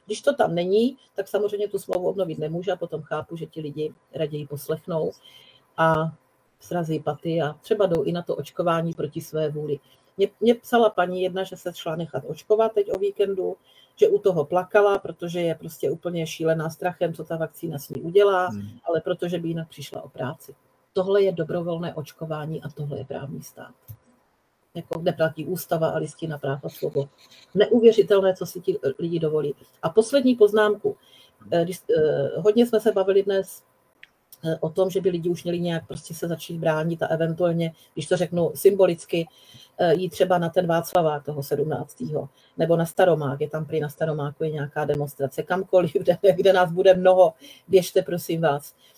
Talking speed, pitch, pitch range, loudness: 175 wpm, 170 Hz, 155-190 Hz, -24 LUFS